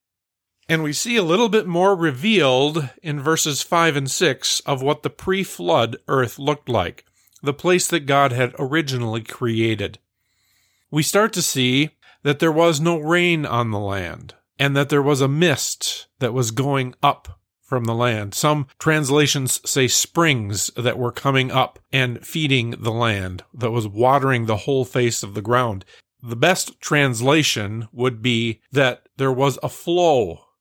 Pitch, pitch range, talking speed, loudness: 135 Hz, 115-150 Hz, 165 wpm, -20 LUFS